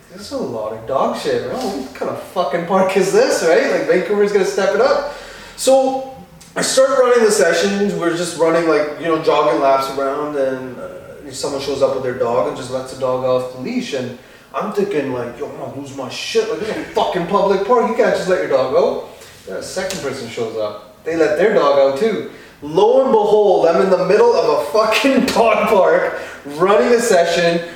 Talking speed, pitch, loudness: 225 wpm, 195 Hz, -16 LUFS